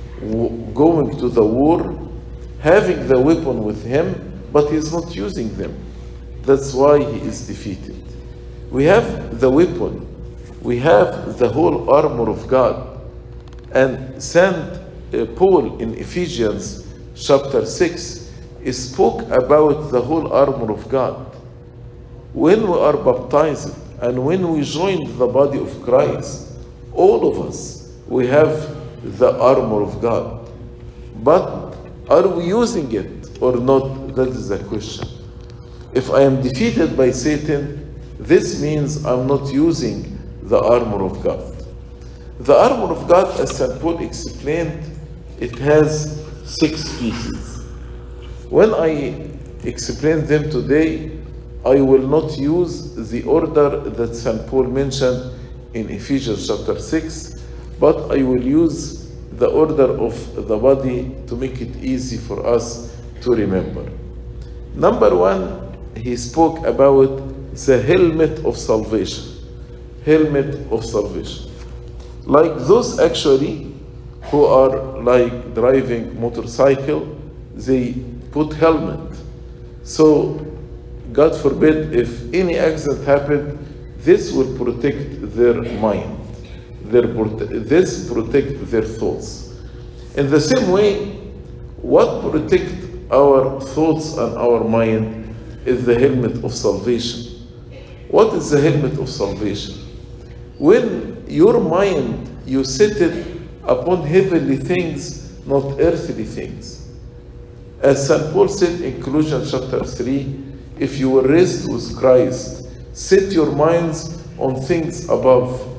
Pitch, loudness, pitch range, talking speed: 130 Hz, -17 LUFS, 120-155 Hz, 120 wpm